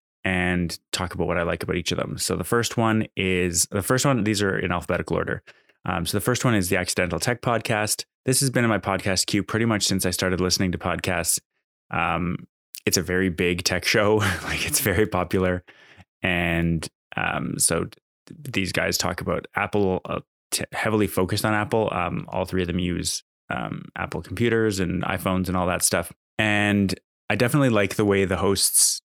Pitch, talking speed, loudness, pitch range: 95 Hz, 200 wpm, -23 LUFS, 90-105 Hz